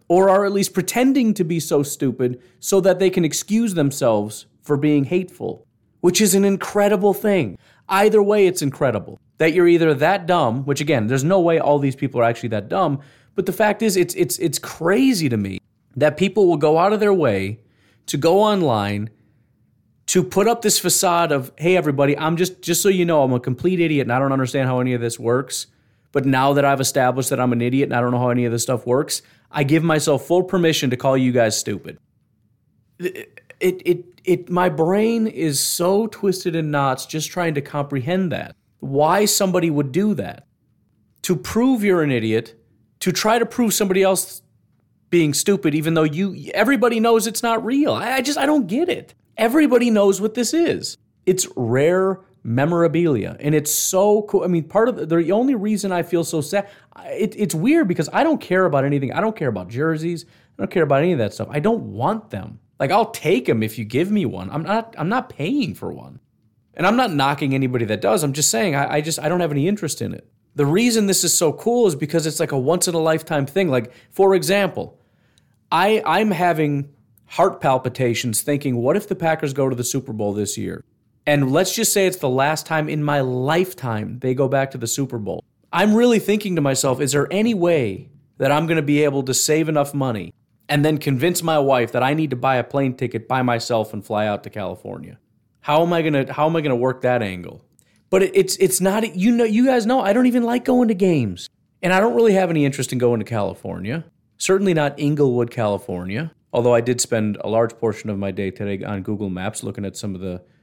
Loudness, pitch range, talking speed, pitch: -19 LUFS, 125-190 Hz, 225 wpm, 155 Hz